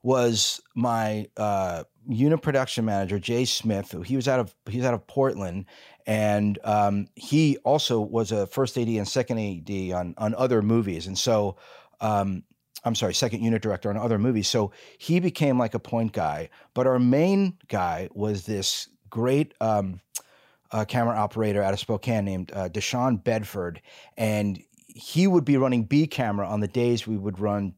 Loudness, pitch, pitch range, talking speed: -25 LUFS, 110 Hz, 100-125 Hz, 175 wpm